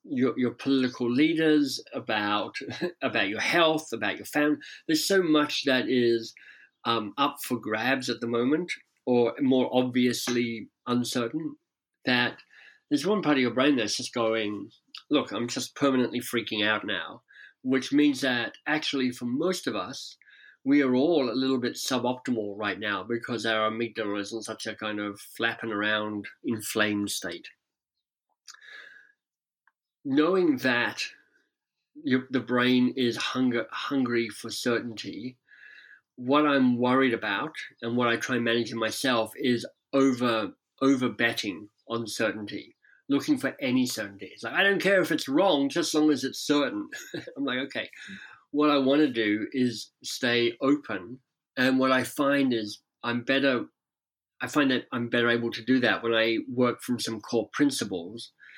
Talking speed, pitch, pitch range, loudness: 160 wpm, 125 Hz, 115-150 Hz, -27 LUFS